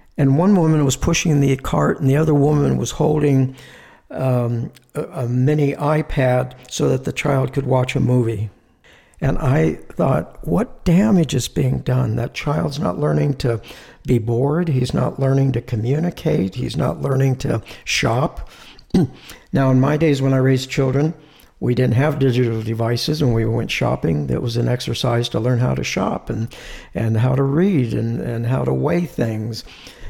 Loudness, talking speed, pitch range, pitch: -19 LUFS, 175 wpm, 120-145 Hz, 130 Hz